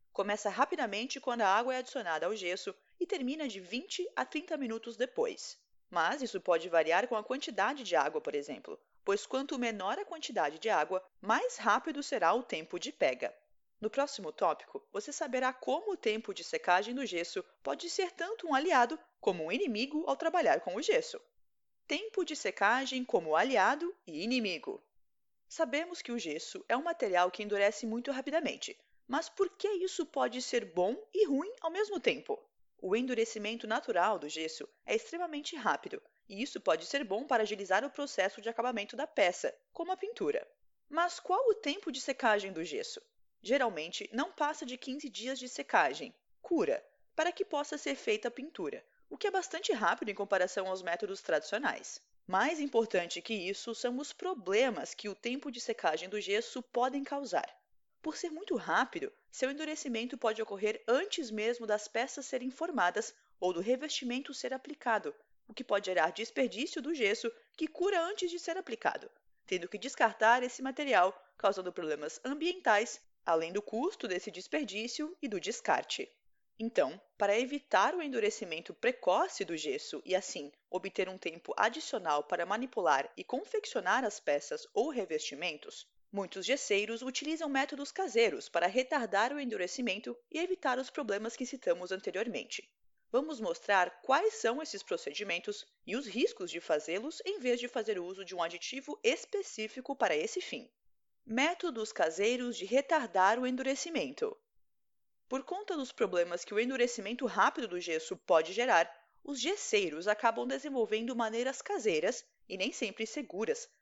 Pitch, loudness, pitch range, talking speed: 260 Hz, -34 LUFS, 215-340 Hz, 160 wpm